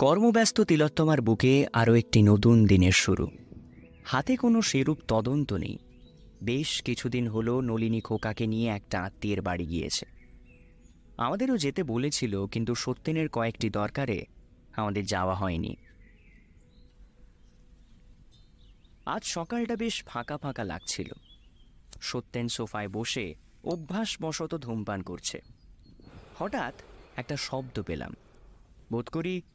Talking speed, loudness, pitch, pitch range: 105 wpm, -28 LUFS, 115 Hz, 100-145 Hz